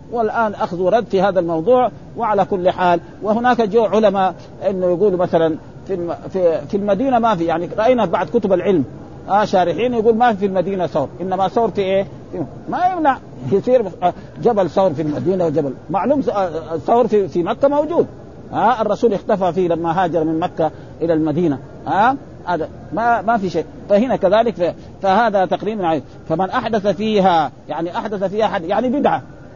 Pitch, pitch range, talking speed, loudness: 195 Hz, 170-225 Hz, 160 wpm, -18 LUFS